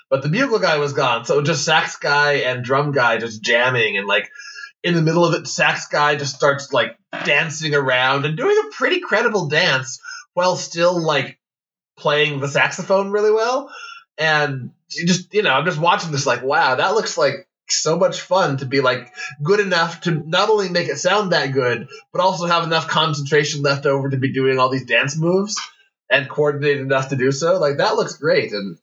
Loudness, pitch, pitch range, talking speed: -18 LUFS, 155 Hz, 140-185 Hz, 205 wpm